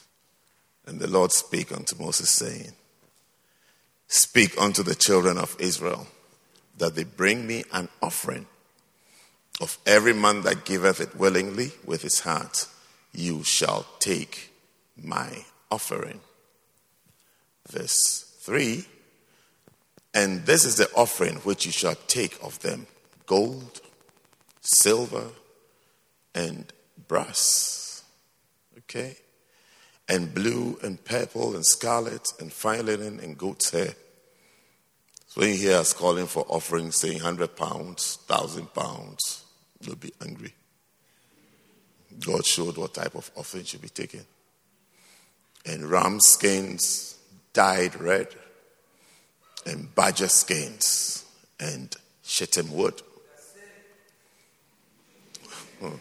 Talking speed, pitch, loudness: 105 wpm, 105 Hz, -24 LUFS